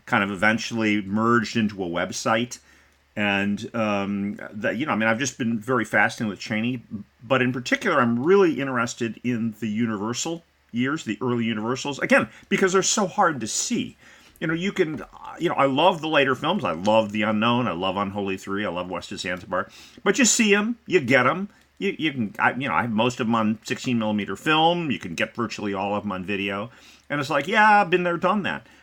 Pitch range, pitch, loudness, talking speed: 105-165 Hz, 115 Hz, -23 LUFS, 220 wpm